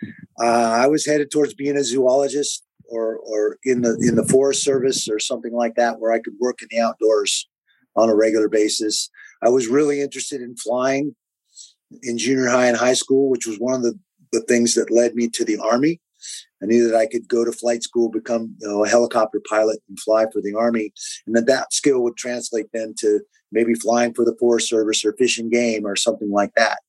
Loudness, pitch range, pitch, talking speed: -19 LUFS, 110-130 Hz, 120 Hz, 215 wpm